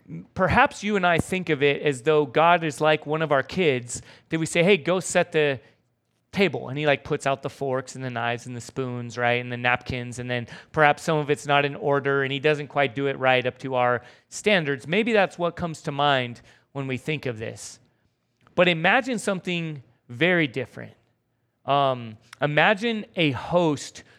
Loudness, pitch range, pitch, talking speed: -23 LUFS, 130-170 Hz, 145 Hz, 200 wpm